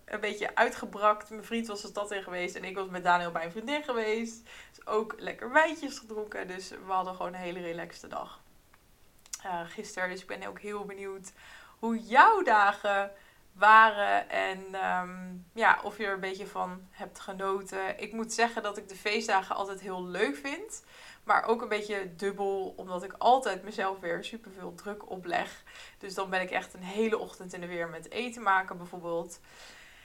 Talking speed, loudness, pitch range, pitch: 190 wpm, -30 LUFS, 185-220 Hz, 200 Hz